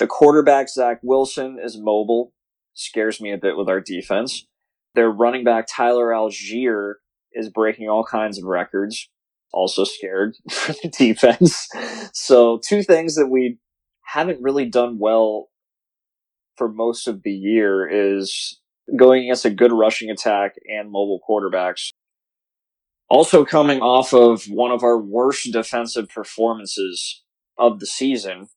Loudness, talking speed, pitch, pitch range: -18 LUFS, 140 wpm, 115 Hz, 105-125 Hz